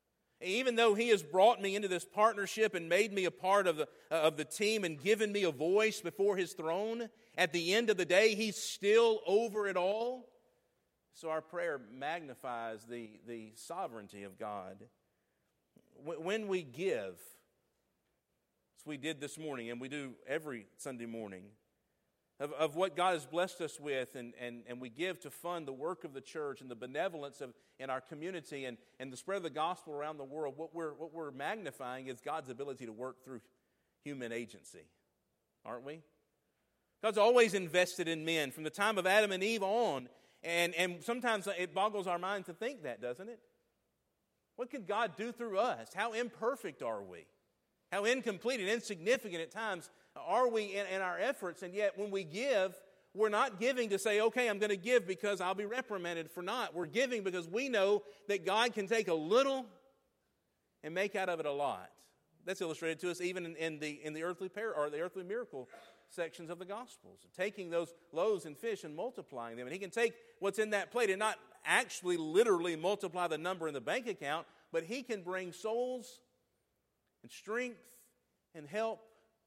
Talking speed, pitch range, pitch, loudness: 195 wpm, 155-220 Hz, 185 Hz, -36 LUFS